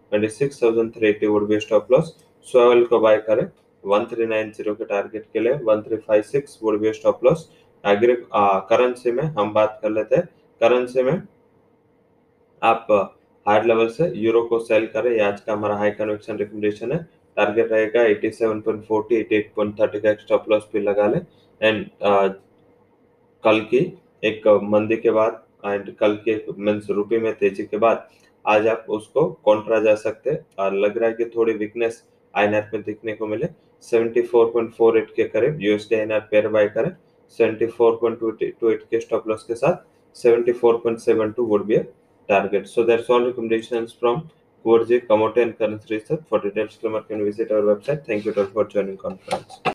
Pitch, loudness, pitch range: 110 Hz, -21 LUFS, 105-115 Hz